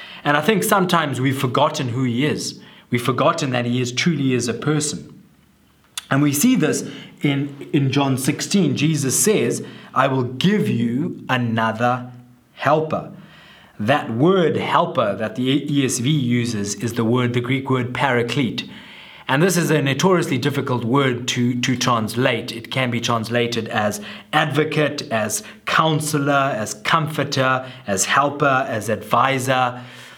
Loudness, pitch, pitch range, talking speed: -19 LUFS, 130 Hz, 120-150 Hz, 145 wpm